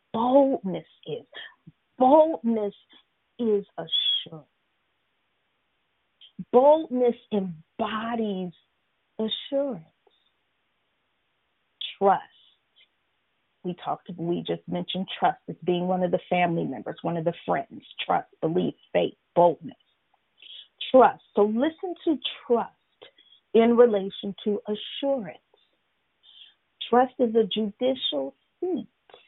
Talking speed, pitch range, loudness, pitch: 90 wpm, 180-265 Hz, -25 LUFS, 220 Hz